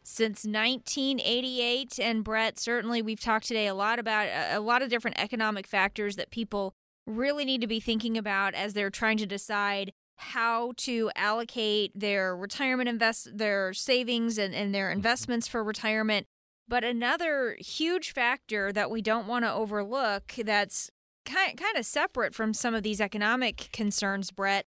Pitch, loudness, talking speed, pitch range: 225 Hz, -29 LUFS, 160 wpm, 205-240 Hz